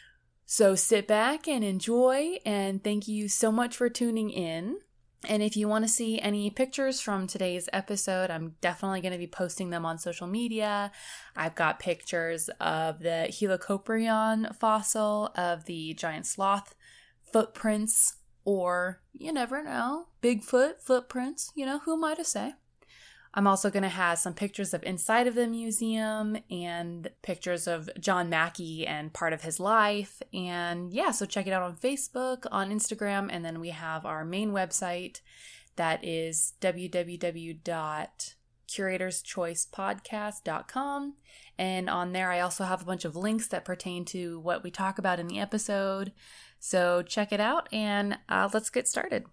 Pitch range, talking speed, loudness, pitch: 175-220 Hz, 160 wpm, -30 LUFS, 195 Hz